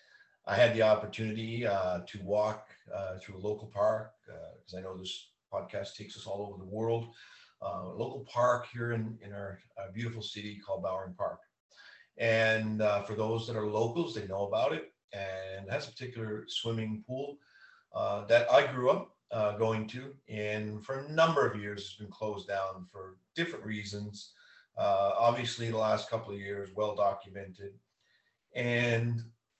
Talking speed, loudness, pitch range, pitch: 175 wpm, -33 LUFS, 100-115 Hz, 110 Hz